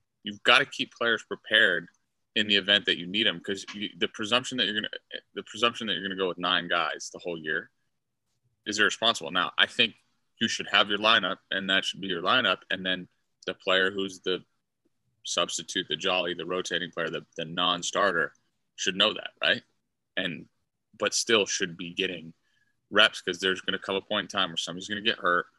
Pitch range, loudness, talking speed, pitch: 90-105 Hz, -26 LUFS, 200 wpm, 95 Hz